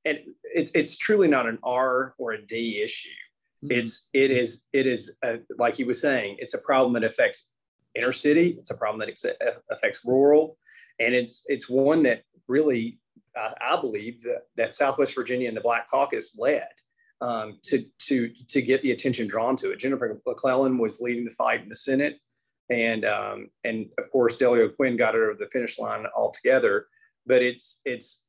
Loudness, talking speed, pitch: -25 LUFS, 185 wpm, 135 Hz